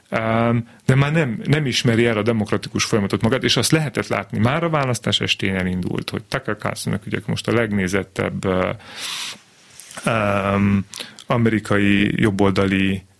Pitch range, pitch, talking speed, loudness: 100-120 Hz, 110 Hz, 135 wpm, -20 LUFS